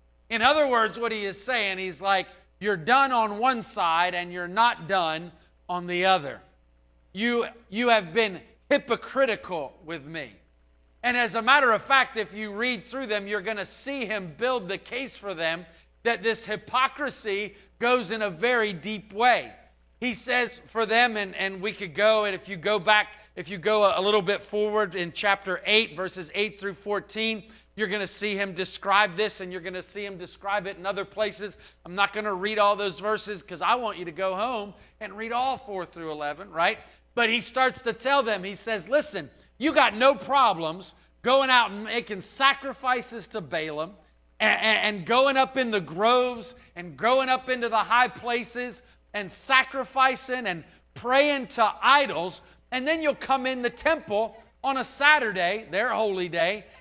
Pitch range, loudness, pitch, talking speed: 190-245 Hz, -25 LUFS, 210 Hz, 185 wpm